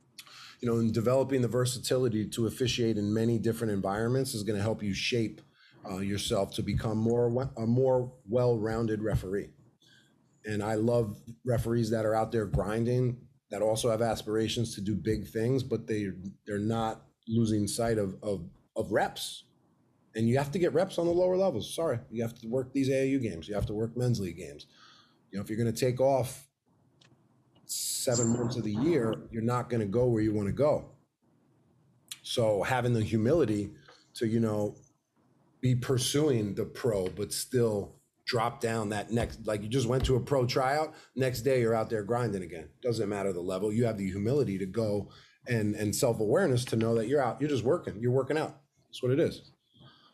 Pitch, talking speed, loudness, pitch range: 115 Hz, 195 wpm, -30 LUFS, 110-125 Hz